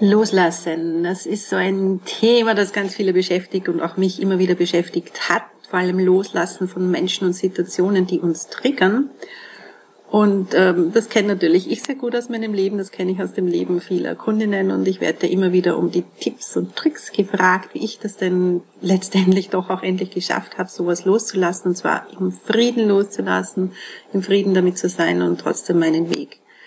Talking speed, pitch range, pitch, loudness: 190 wpm, 175-200 Hz, 185 Hz, -19 LUFS